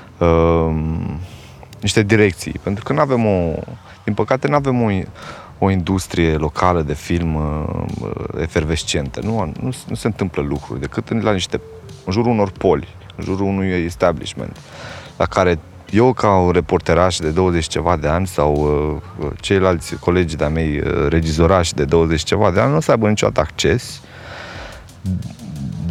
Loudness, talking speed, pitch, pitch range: -18 LUFS, 160 wpm, 90 Hz, 80-105 Hz